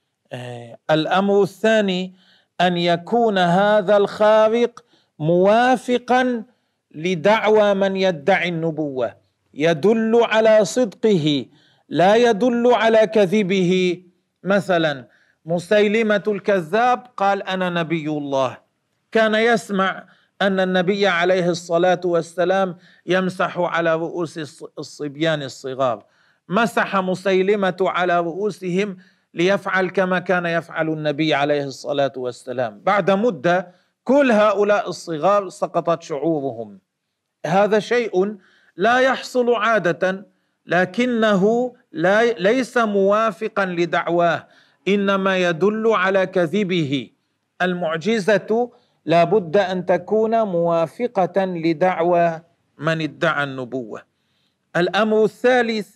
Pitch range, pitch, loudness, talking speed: 170-215 Hz, 185 Hz, -19 LUFS, 90 wpm